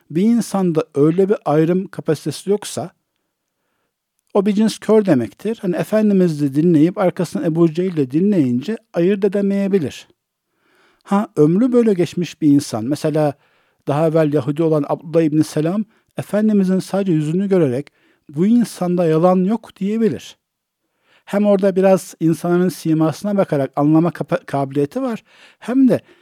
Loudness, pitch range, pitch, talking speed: -17 LUFS, 155-205 Hz, 180 Hz, 130 wpm